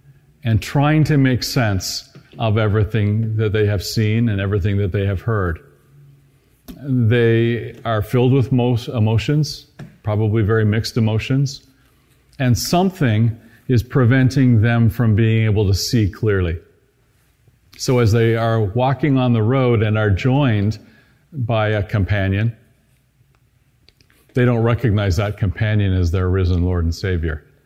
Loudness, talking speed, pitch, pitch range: -18 LUFS, 135 wpm, 115 Hz, 105-130 Hz